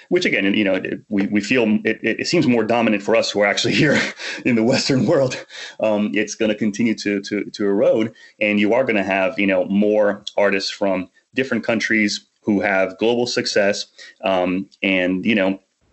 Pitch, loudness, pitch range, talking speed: 105 Hz, -19 LUFS, 95-105 Hz, 190 wpm